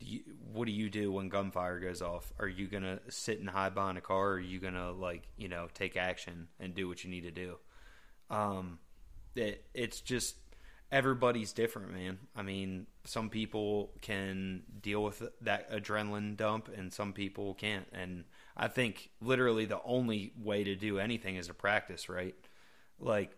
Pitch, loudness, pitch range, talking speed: 100 Hz, -37 LUFS, 90-105 Hz, 180 wpm